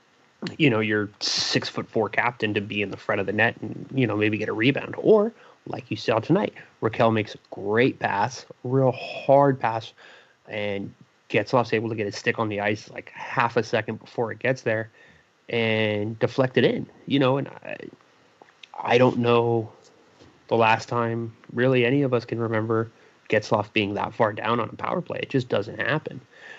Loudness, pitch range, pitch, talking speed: -24 LUFS, 110-125 Hz, 115 Hz, 195 wpm